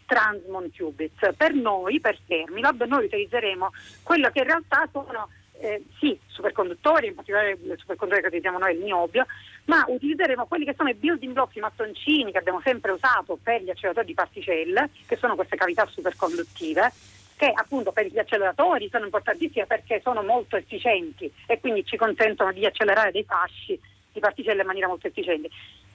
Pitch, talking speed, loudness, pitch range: 220 Hz, 170 wpm, -24 LUFS, 190-280 Hz